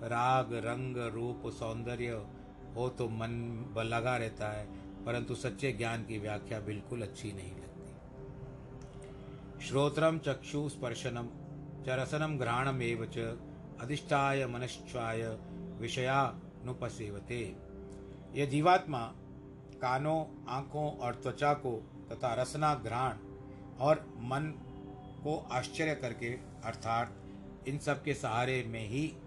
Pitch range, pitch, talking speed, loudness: 115-145 Hz, 125 Hz, 105 wpm, -36 LUFS